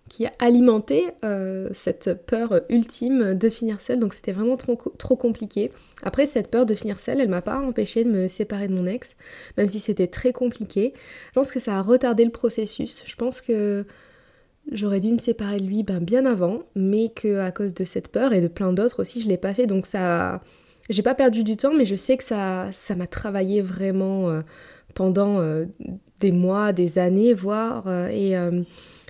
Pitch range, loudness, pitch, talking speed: 190-240 Hz, -23 LUFS, 210 Hz, 210 wpm